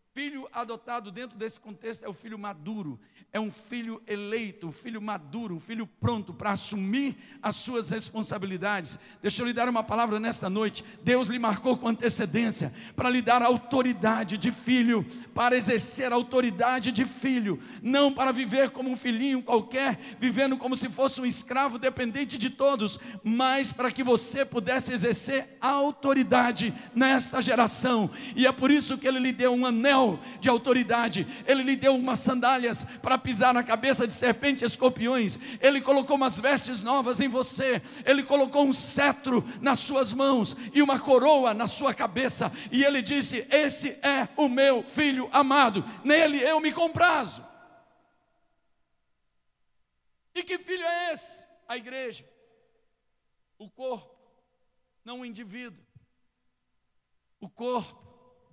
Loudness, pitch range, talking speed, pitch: -26 LUFS, 225-270 Hz, 150 wpm, 250 Hz